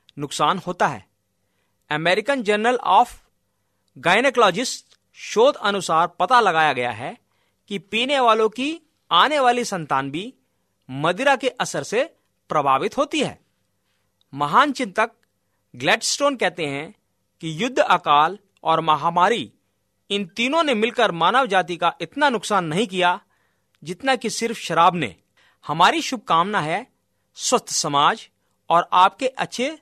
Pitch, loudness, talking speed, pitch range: 185 Hz, -20 LUFS, 125 wpm, 150-245 Hz